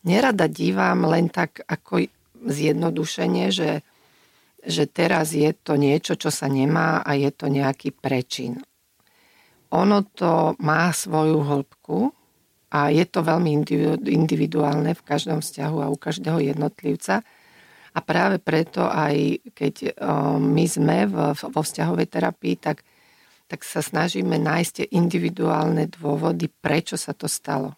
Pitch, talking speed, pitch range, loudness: 155 Hz, 125 wpm, 145-160 Hz, -22 LUFS